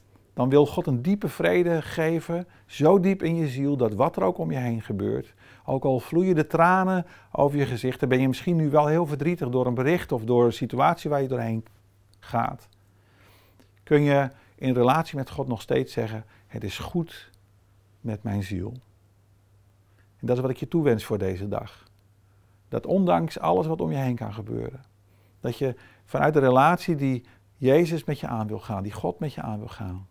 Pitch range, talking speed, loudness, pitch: 100-150 Hz, 200 wpm, -25 LUFS, 125 Hz